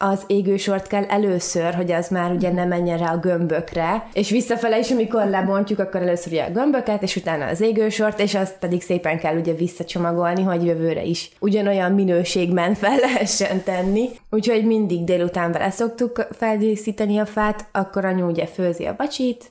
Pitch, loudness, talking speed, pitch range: 195 Hz, -21 LUFS, 170 wpm, 175-215 Hz